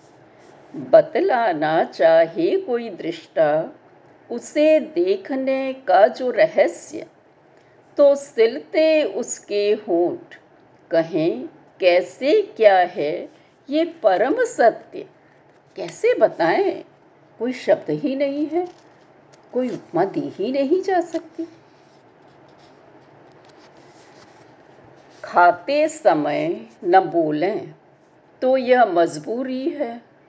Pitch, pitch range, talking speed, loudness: 310 Hz, 255-340 Hz, 85 wpm, -20 LUFS